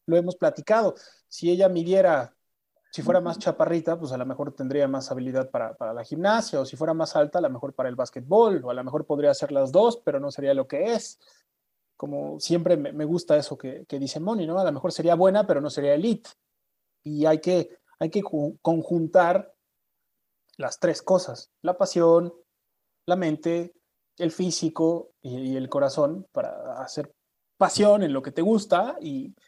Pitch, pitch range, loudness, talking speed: 170 Hz, 145-190 Hz, -24 LUFS, 190 wpm